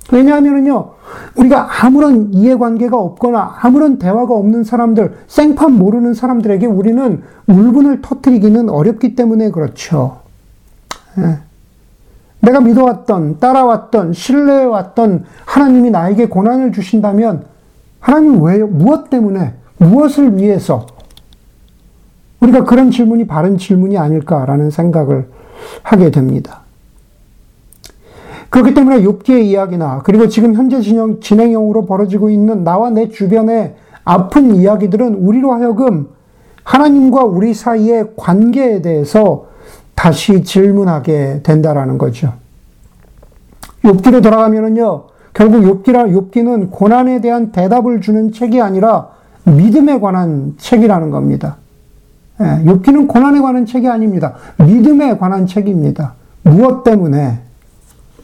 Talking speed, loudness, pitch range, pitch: 285 characters per minute, -10 LUFS, 175-245 Hz, 215 Hz